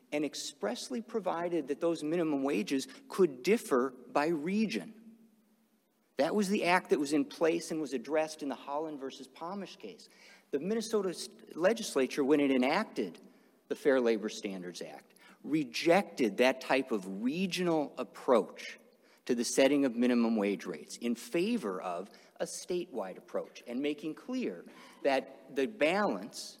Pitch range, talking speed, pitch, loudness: 135-200 Hz, 145 wpm, 155 Hz, -33 LUFS